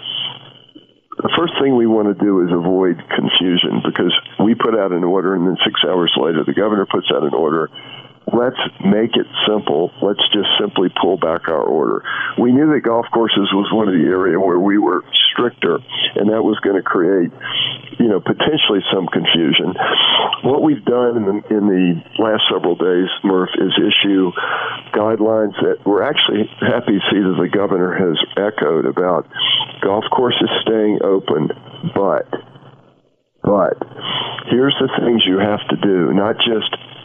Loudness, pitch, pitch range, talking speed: -15 LUFS, 110 Hz, 95-120 Hz, 170 wpm